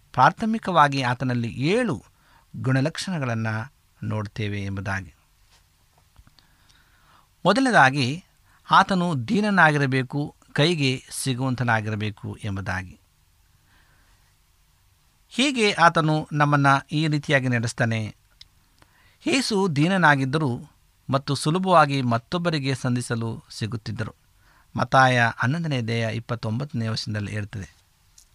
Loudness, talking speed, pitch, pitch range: -23 LUFS, 65 wpm, 125 Hz, 105-150 Hz